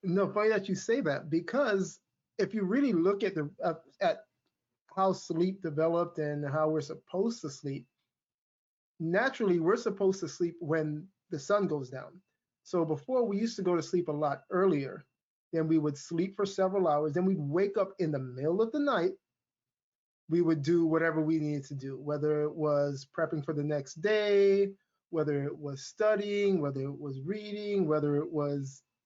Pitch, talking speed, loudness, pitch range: 170 Hz, 185 wpm, -31 LUFS, 150-195 Hz